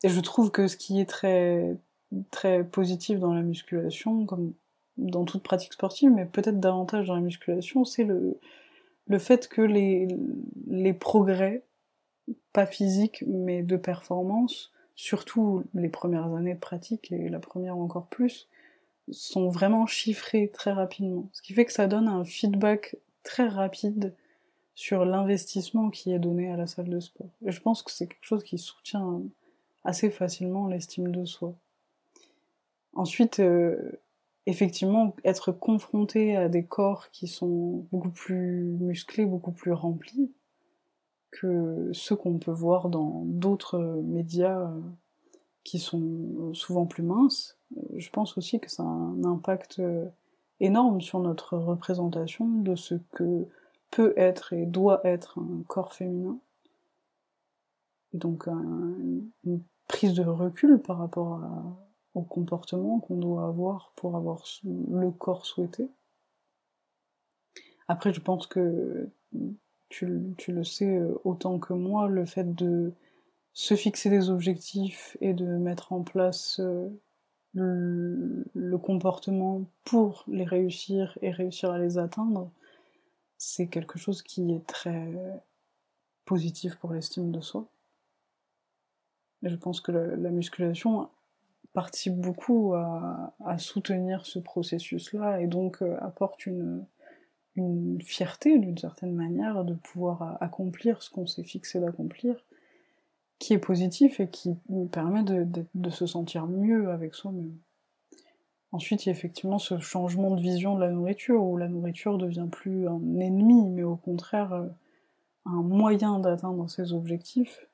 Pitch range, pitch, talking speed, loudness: 175-210 Hz, 185 Hz, 140 wpm, -28 LUFS